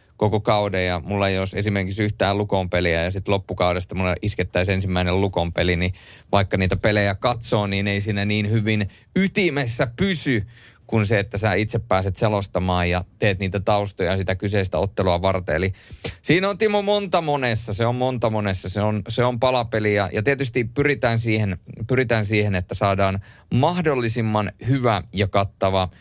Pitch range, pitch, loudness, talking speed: 95-115 Hz, 105 Hz, -21 LUFS, 160 wpm